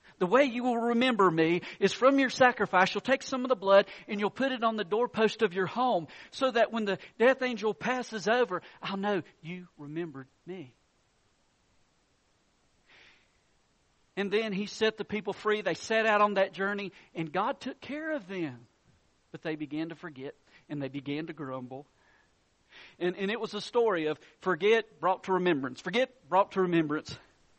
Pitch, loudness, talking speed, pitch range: 195 Hz, -29 LUFS, 180 wpm, 165-225 Hz